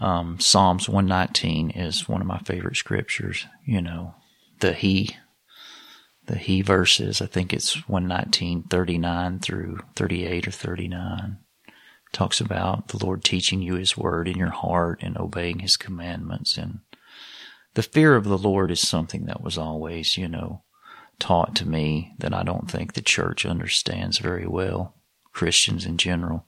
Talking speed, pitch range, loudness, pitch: 155 wpm, 85-95 Hz, -23 LUFS, 90 Hz